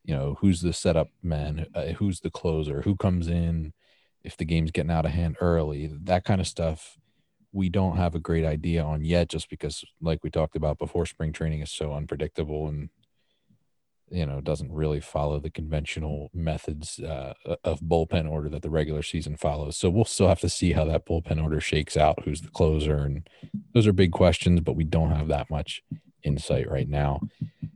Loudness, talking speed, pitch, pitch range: -27 LUFS, 200 wpm, 80 Hz, 75-85 Hz